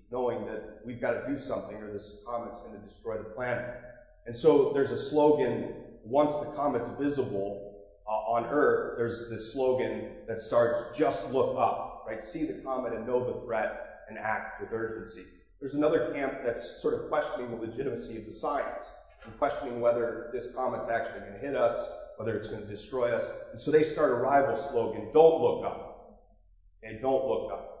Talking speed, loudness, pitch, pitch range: 190 wpm, -30 LUFS, 120 Hz, 110-145 Hz